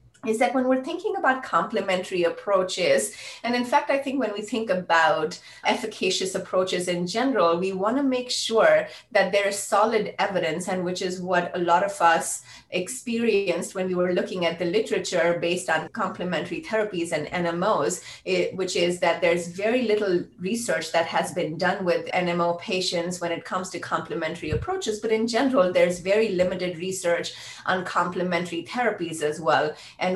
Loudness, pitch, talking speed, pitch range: -24 LUFS, 185 Hz, 170 wpm, 170-215 Hz